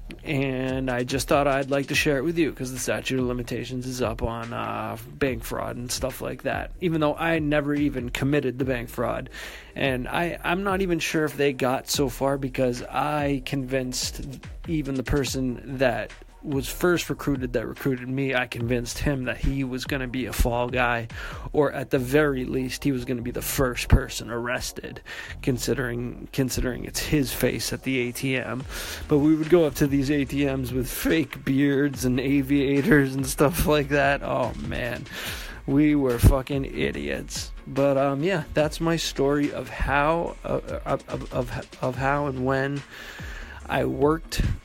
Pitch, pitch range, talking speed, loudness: 135 Hz, 125-145 Hz, 175 wpm, -25 LUFS